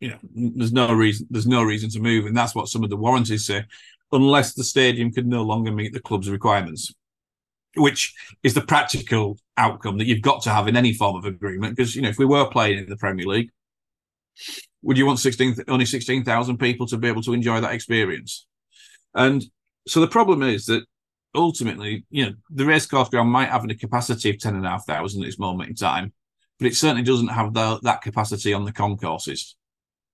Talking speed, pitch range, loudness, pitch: 215 wpm, 105-130 Hz, -21 LUFS, 115 Hz